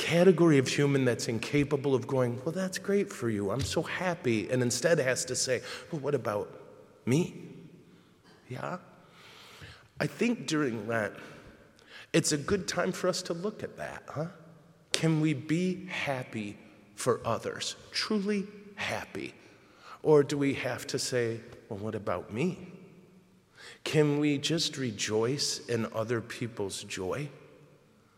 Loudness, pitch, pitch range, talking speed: -30 LUFS, 145 Hz, 115-170 Hz, 140 wpm